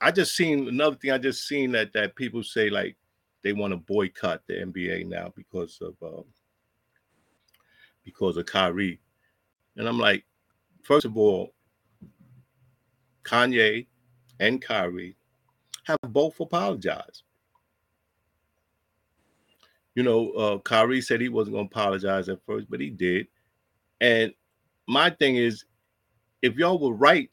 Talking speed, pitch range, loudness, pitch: 130 wpm, 100-130 Hz, -25 LUFS, 110 Hz